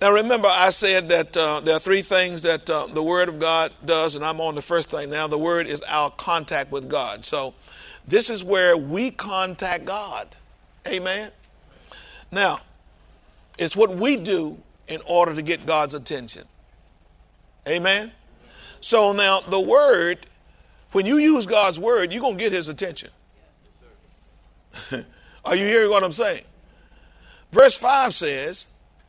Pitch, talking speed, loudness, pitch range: 175 Hz, 155 wpm, -21 LUFS, 155-195 Hz